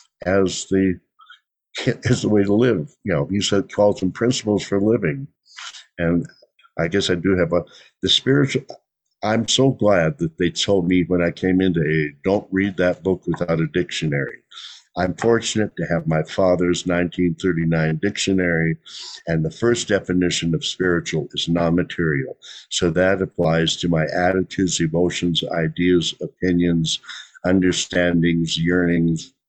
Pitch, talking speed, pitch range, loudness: 90 Hz, 150 wpm, 85-95 Hz, -20 LUFS